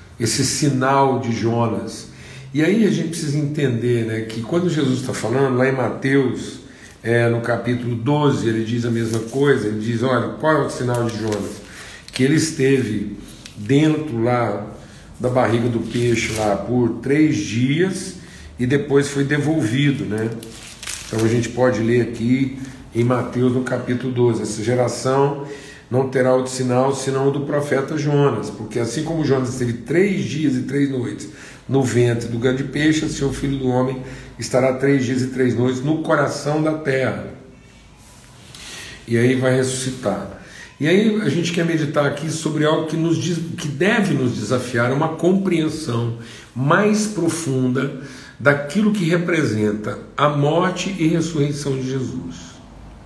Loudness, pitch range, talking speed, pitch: -19 LUFS, 120-145 Hz, 160 wpm, 130 Hz